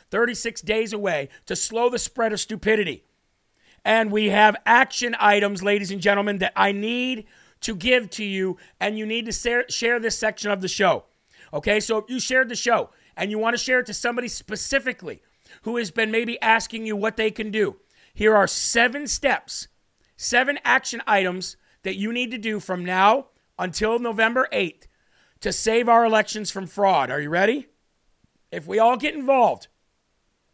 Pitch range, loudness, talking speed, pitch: 205-235 Hz, -22 LUFS, 180 wpm, 220 Hz